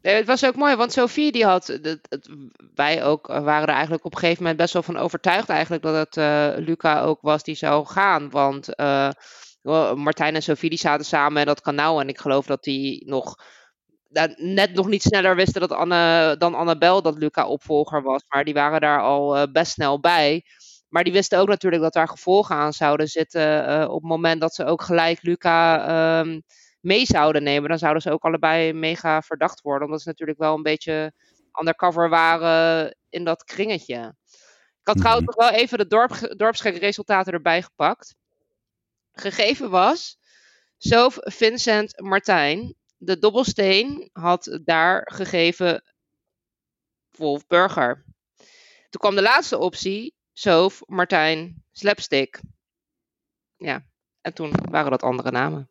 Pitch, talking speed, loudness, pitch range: 165 Hz, 165 wpm, -20 LUFS, 150-190 Hz